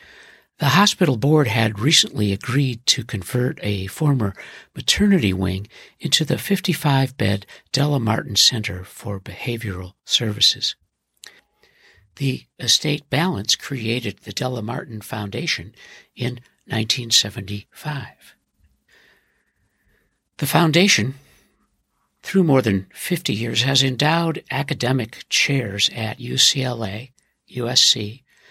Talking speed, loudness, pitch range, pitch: 95 wpm, -19 LUFS, 105-145 Hz, 125 Hz